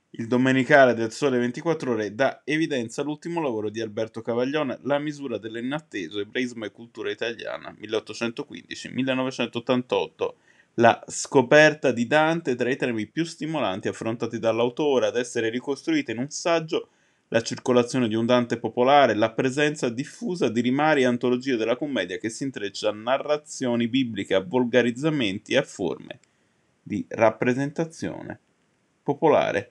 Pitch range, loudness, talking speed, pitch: 115-150 Hz, -24 LUFS, 135 wpm, 125 Hz